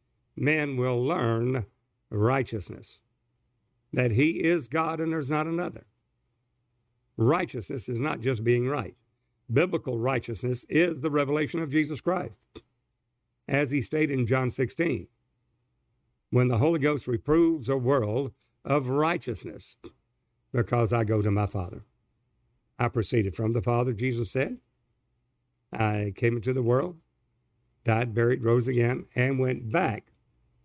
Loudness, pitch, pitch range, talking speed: -27 LUFS, 125 Hz, 120-140 Hz, 130 wpm